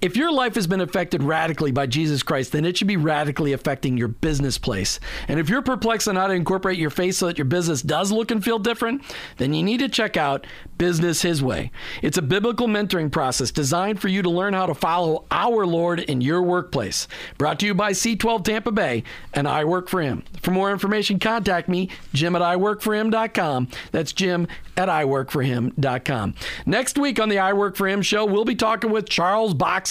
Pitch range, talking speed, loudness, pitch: 150-210 Hz, 210 wpm, -22 LUFS, 180 Hz